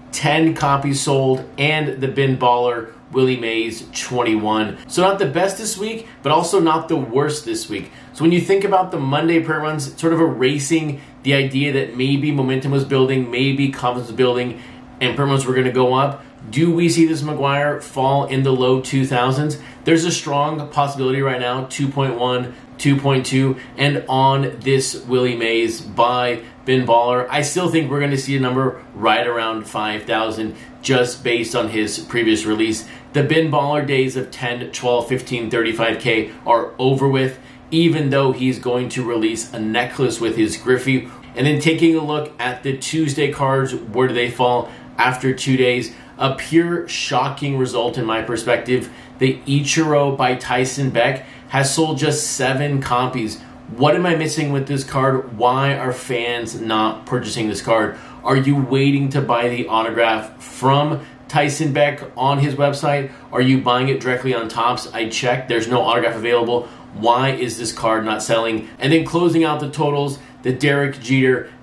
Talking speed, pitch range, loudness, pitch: 175 wpm, 120-145 Hz, -18 LUFS, 130 Hz